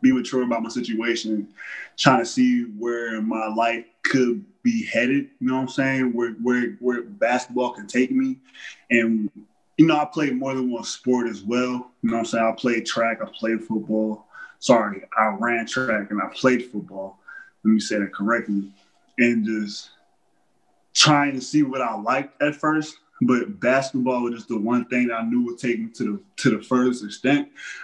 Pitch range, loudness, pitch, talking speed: 115-130 Hz, -22 LUFS, 120 Hz, 195 wpm